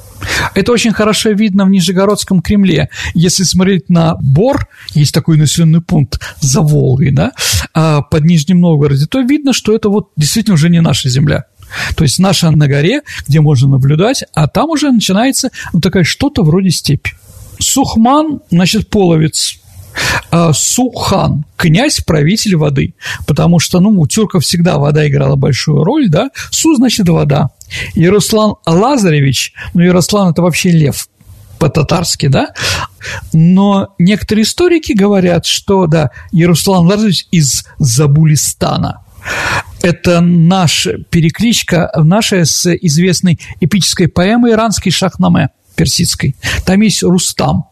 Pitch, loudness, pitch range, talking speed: 170 Hz, -10 LUFS, 150-195 Hz, 130 wpm